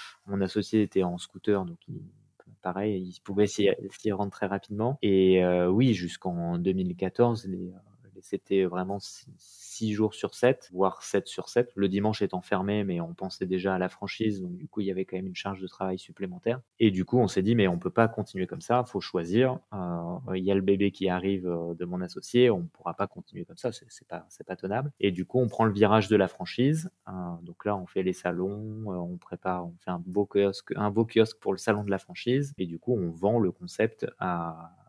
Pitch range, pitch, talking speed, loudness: 90-110 Hz, 100 Hz, 235 wpm, -29 LUFS